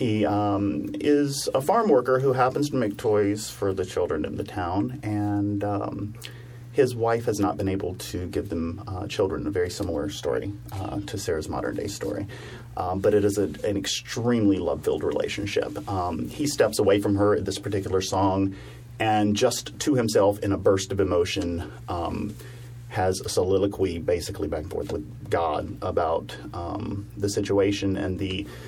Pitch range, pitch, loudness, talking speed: 95-120 Hz, 105 Hz, -26 LUFS, 180 wpm